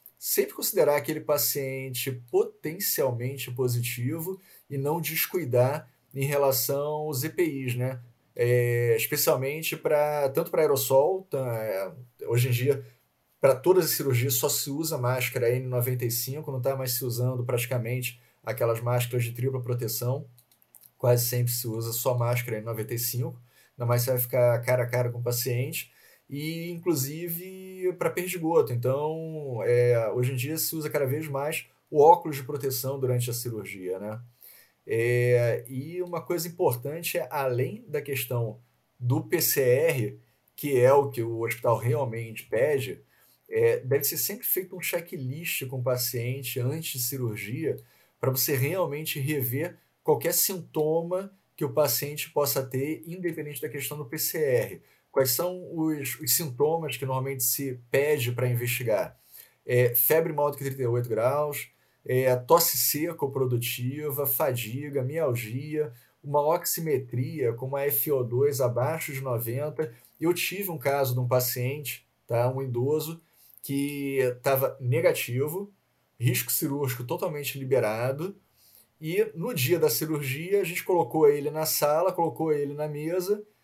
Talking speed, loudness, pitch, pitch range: 140 wpm, -27 LUFS, 135 Hz, 125-155 Hz